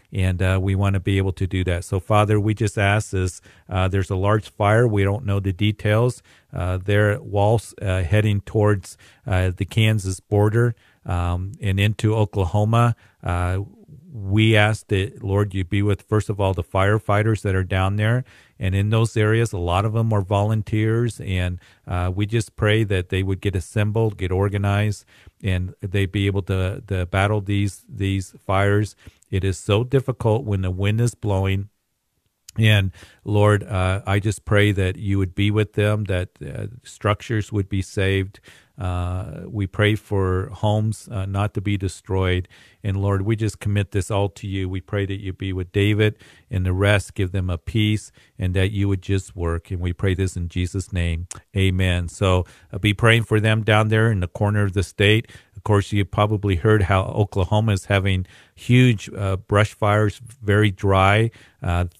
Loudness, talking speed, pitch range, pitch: -21 LUFS, 190 wpm, 95-105 Hz, 100 Hz